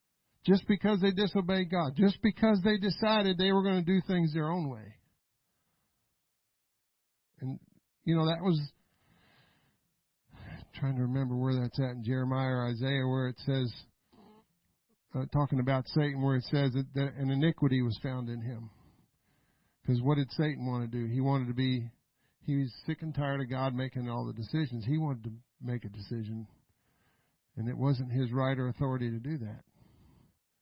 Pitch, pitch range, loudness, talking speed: 135 Hz, 125-160 Hz, -32 LUFS, 175 wpm